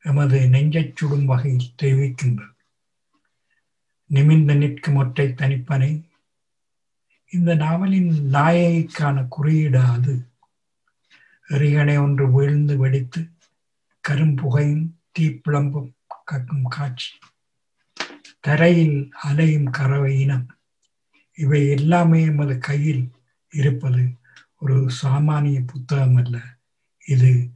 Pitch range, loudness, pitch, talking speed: 135-150 Hz, -19 LUFS, 140 Hz, 80 wpm